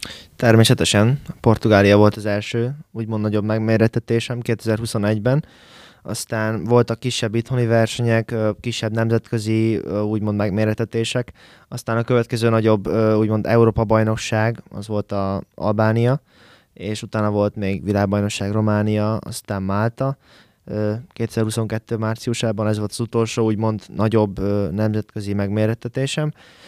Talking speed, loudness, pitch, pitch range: 105 wpm, -20 LUFS, 110 Hz, 105-115 Hz